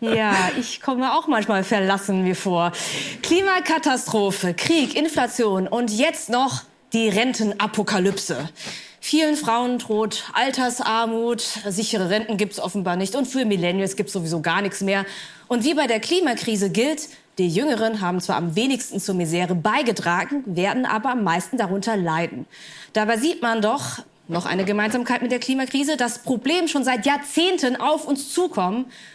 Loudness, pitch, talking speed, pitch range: -22 LUFS, 225 Hz, 150 wpm, 195-260 Hz